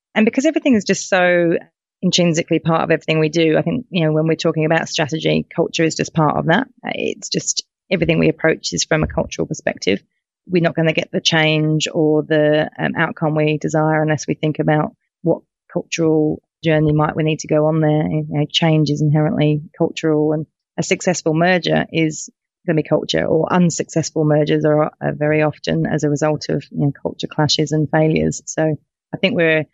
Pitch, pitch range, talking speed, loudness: 155 Hz, 155-165 Hz, 200 wpm, -17 LUFS